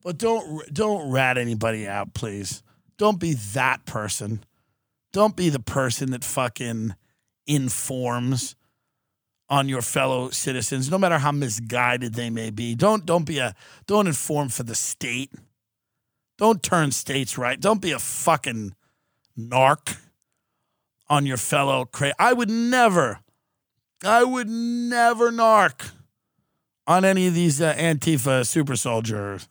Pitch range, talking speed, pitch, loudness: 120-170 Hz, 135 wpm, 135 Hz, -22 LUFS